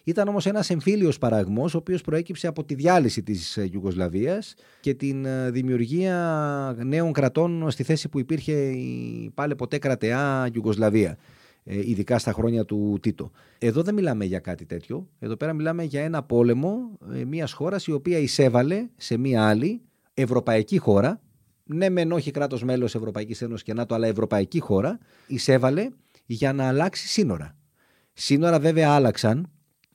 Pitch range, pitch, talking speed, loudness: 115-165 Hz, 135 Hz, 150 wpm, -24 LUFS